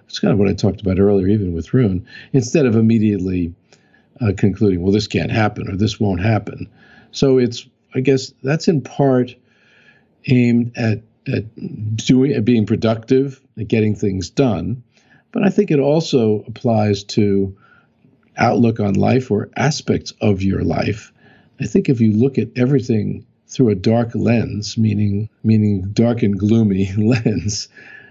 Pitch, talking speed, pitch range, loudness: 110 Hz, 160 wpm, 105-125 Hz, -17 LUFS